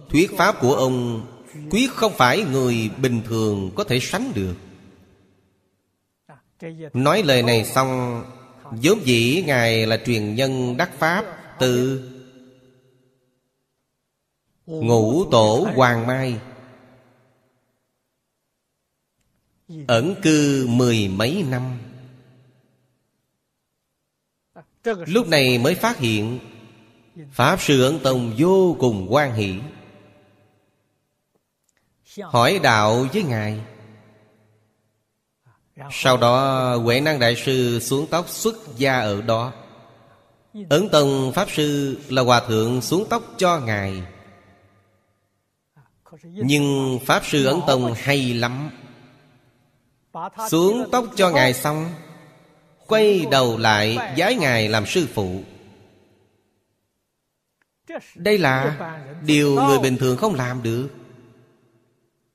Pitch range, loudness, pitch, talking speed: 115-145 Hz, -19 LUFS, 125 Hz, 100 wpm